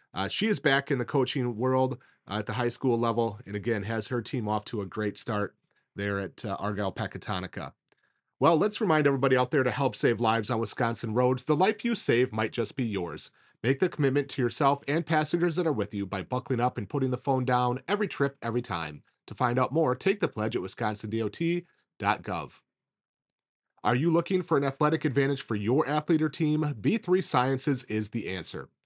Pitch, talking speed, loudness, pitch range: 125 Hz, 205 wpm, -28 LUFS, 110-150 Hz